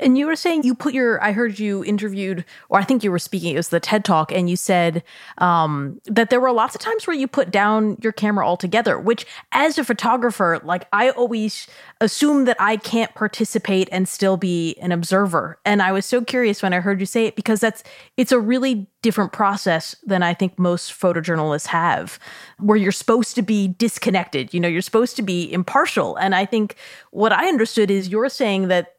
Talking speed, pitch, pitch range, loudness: 215 wpm, 205 Hz, 180-235 Hz, -19 LUFS